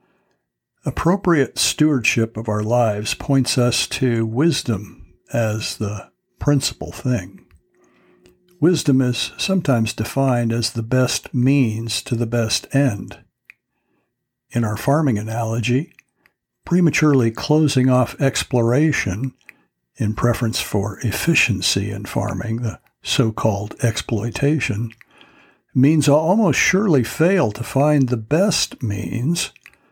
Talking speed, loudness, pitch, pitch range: 105 wpm, -19 LUFS, 120 Hz, 110-140 Hz